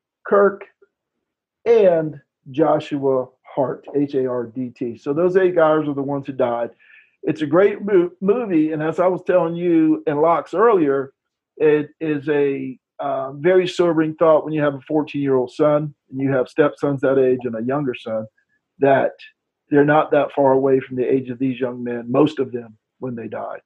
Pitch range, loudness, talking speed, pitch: 130-160 Hz, -19 LUFS, 185 wpm, 145 Hz